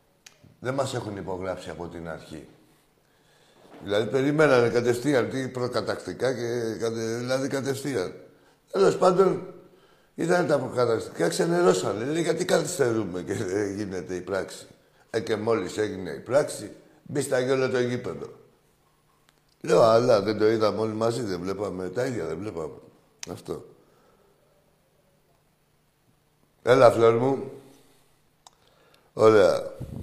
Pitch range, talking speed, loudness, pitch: 105-135 Hz, 115 wpm, -25 LUFS, 120 Hz